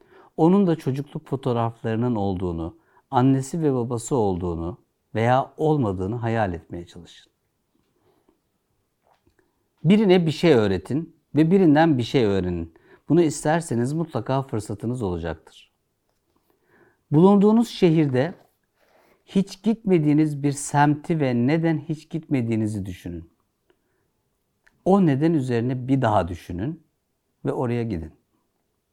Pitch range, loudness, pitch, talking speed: 110-160 Hz, -22 LUFS, 135 Hz, 100 wpm